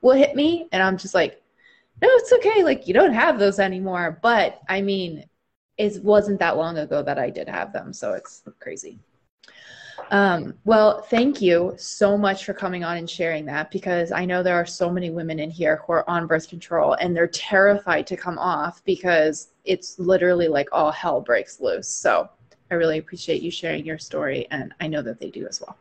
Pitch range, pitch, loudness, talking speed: 170-205 Hz, 180 Hz, -21 LUFS, 205 wpm